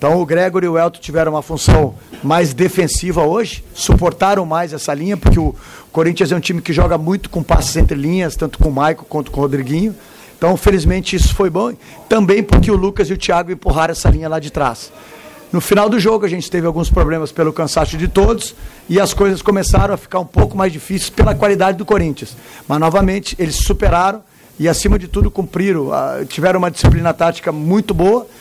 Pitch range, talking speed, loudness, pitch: 155-195 Hz, 205 wpm, -15 LUFS, 175 Hz